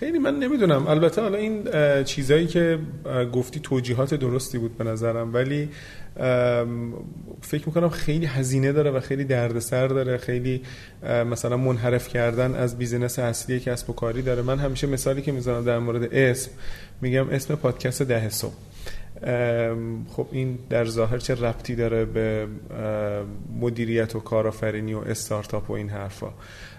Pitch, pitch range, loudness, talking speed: 125 Hz, 115-135 Hz, -25 LUFS, 145 wpm